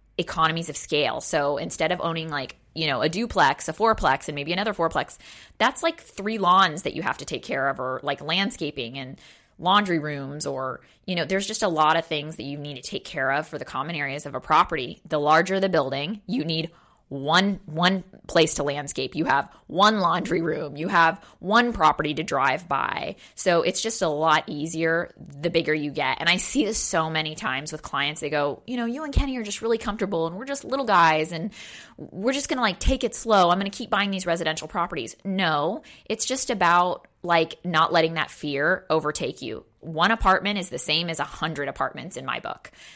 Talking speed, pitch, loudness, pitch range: 215 wpm, 165 Hz, -24 LUFS, 155-200 Hz